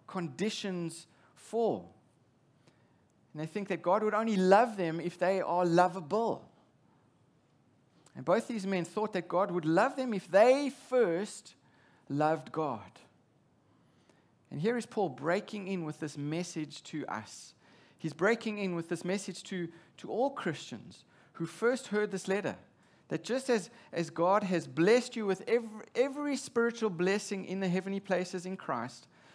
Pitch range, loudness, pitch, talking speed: 165-215 Hz, -32 LUFS, 185 Hz, 155 wpm